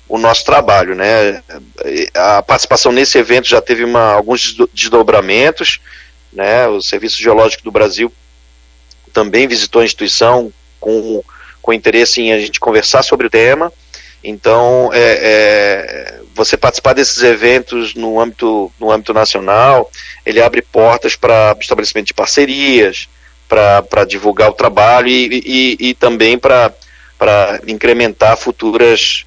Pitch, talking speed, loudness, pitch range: 115 Hz, 130 wpm, -10 LUFS, 105-125 Hz